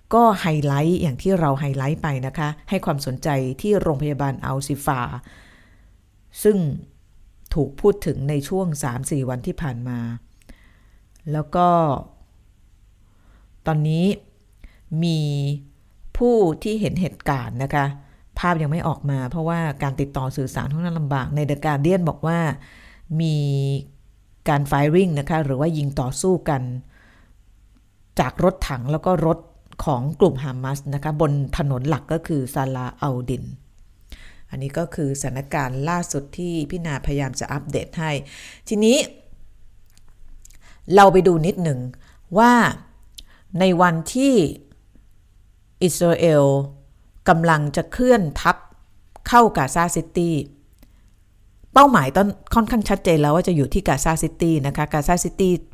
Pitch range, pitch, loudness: 125-170 Hz, 145 Hz, -21 LUFS